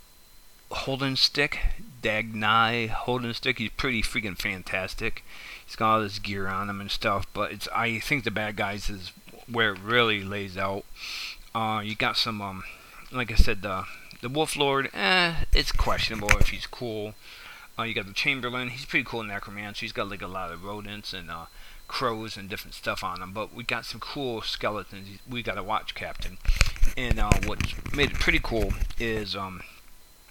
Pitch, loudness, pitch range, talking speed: 105 Hz, -28 LUFS, 100-115 Hz, 185 wpm